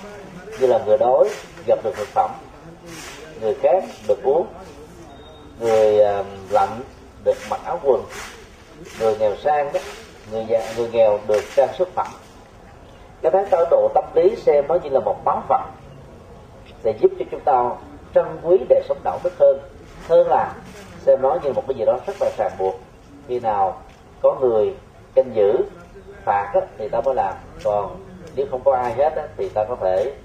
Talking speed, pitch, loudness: 185 wpm, 215 Hz, -20 LUFS